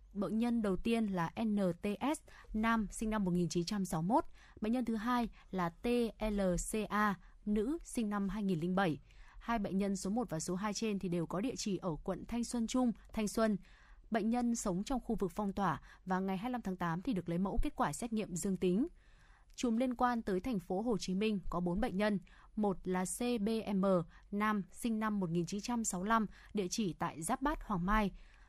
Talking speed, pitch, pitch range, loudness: 190 wpm, 205 Hz, 185-230 Hz, -36 LUFS